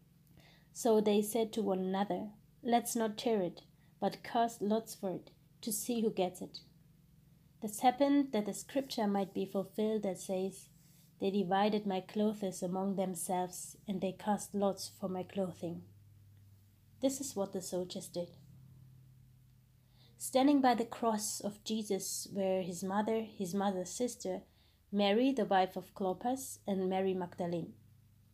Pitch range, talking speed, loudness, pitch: 160-210 Hz, 145 wpm, -35 LUFS, 190 Hz